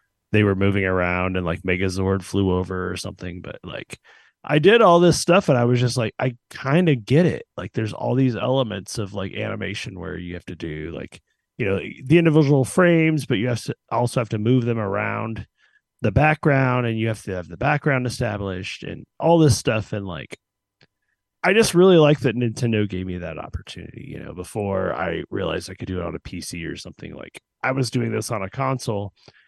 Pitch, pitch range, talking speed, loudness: 110 Hz, 95-130 Hz, 215 wpm, -21 LUFS